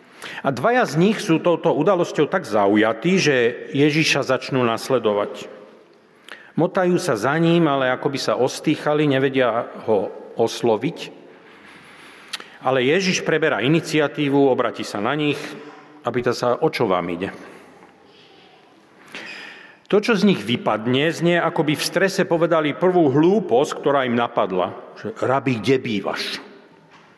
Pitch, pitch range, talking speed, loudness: 150 Hz, 130-175 Hz, 130 wpm, -20 LUFS